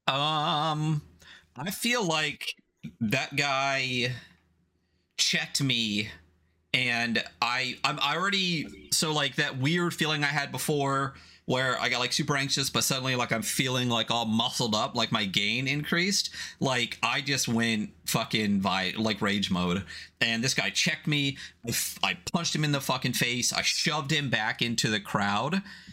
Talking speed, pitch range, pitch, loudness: 160 wpm, 115-155 Hz, 135 Hz, -27 LUFS